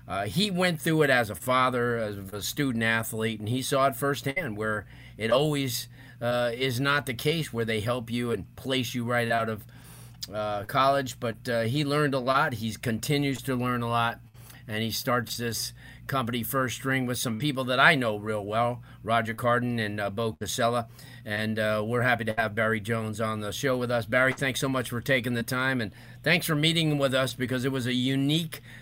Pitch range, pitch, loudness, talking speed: 115-135 Hz, 120 Hz, -27 LUFS, 210 wpm